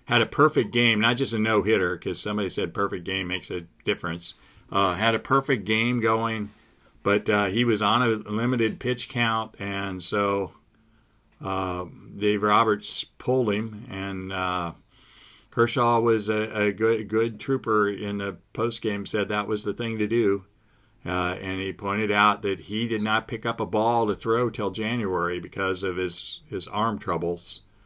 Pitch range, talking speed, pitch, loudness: 100-115 Hz, 170 wpm, 105 Hz, -25 LUFS